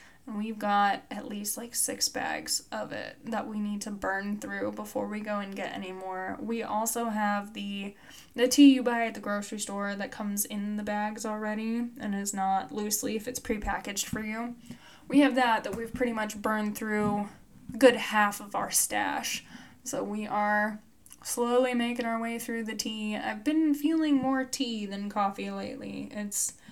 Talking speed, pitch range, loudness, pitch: 185 wpm, 205-235 Hz, -29 LUFS, 215 Hz